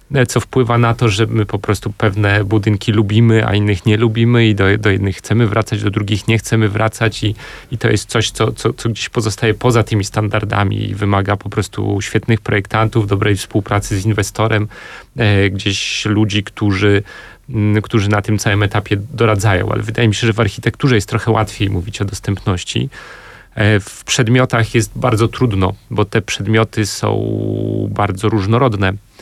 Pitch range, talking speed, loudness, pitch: 105-115 Hz, 170 wpm, -15 LUFS, 110 Hz